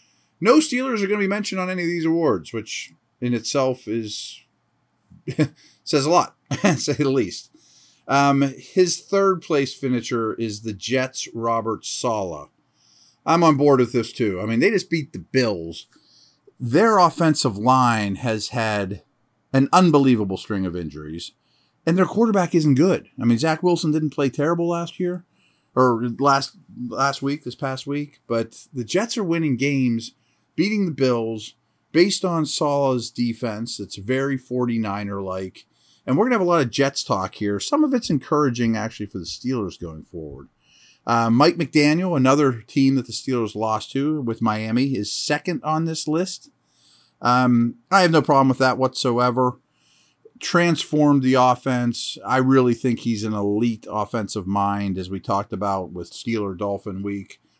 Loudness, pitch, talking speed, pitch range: -21 LUFS, 130 Hz, 165 wpm, 115-155 Hz